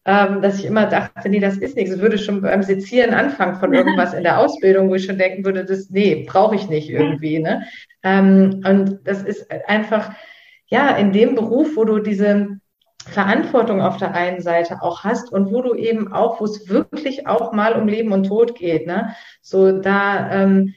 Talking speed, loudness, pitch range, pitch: 200 wpm, -17 LUFS, 190-225 Hz, 200 Hz